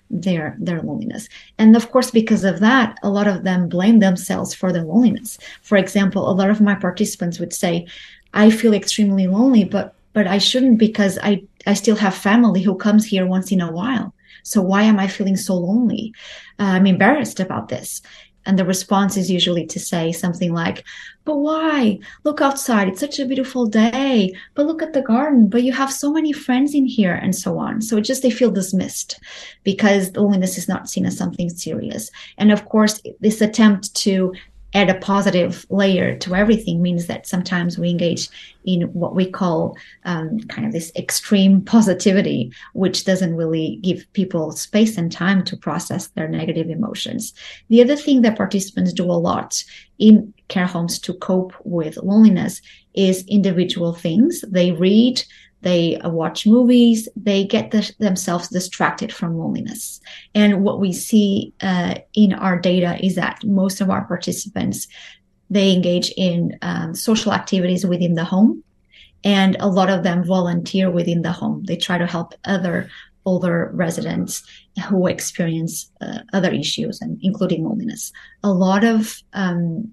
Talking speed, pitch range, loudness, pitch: 170 wpm, 180-220 Hz, -18 LUFS, 195 Hz